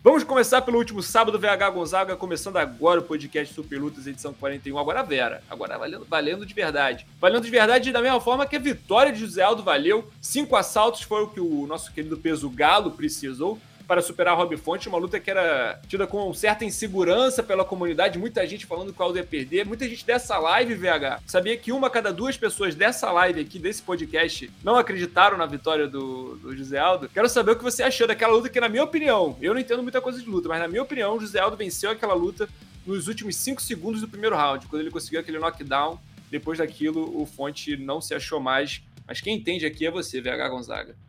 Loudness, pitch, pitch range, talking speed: -24 LUFS, 190 Hz, 160-235 Hz, 220 wpm